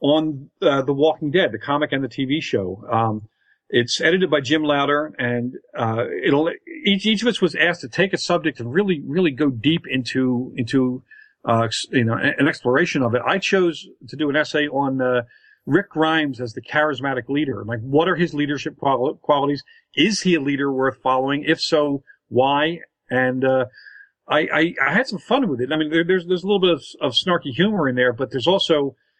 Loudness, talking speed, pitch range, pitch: -20 LUFS, 210 wpm, 130-170 Hz, 145 Hz